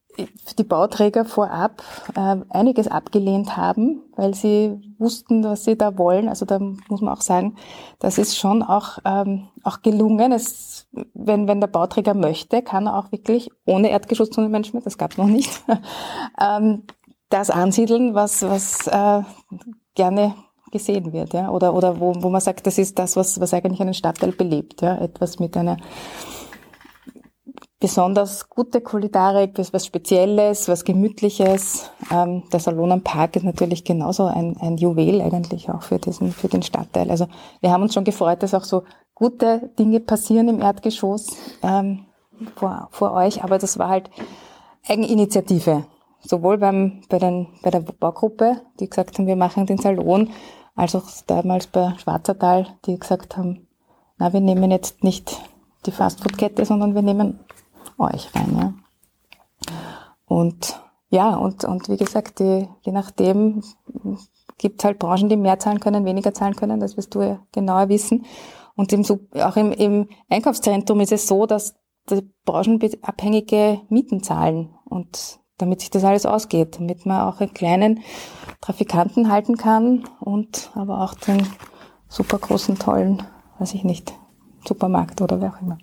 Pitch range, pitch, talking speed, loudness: 185-215 Hz, 200 Hz, 155 wpm, -20 LUFS